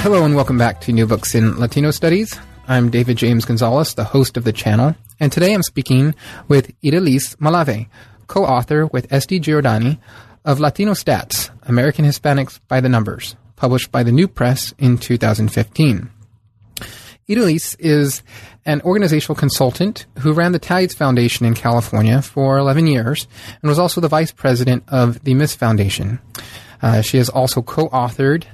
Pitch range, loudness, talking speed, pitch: 115-150 Hz, -16 LUFS, 160 wpm, 130 Hz